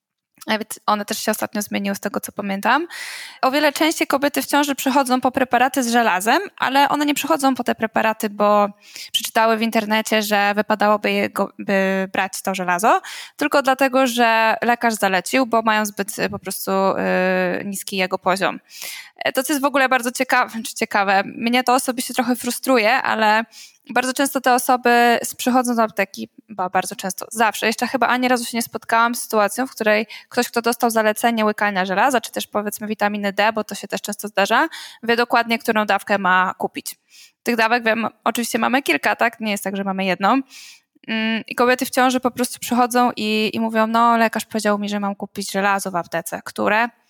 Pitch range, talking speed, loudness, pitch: 205-255 Hz, 185 wpm, -19 LUFS, 225 Hz